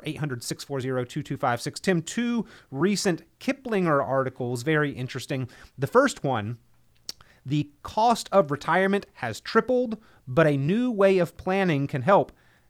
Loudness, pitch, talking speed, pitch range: -25 LUFS, 150 Hz, 125 wpm, 130-195 Hz